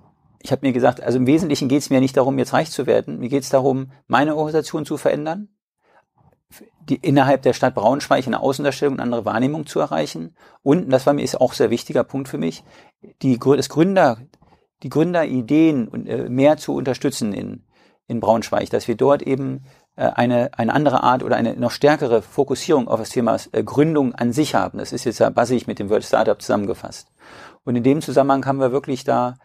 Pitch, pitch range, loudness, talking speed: 135 Hz, 125-150 Hz, -19 LUFS, 210 wpm